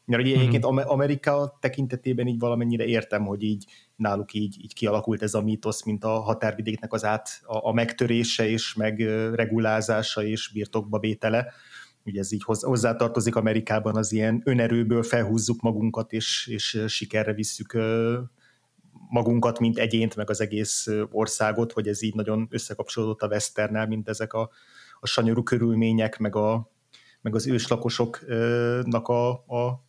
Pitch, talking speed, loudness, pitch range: 110 Hz, 140 wpm, -26 LUFS, 110-120 Hz